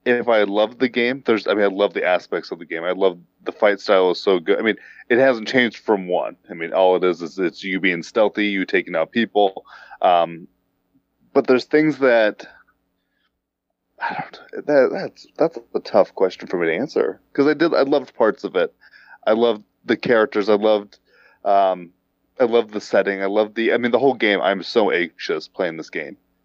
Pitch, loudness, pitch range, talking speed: 105 Hz, -19 LUFS, 95-120 Hz, 215 wpm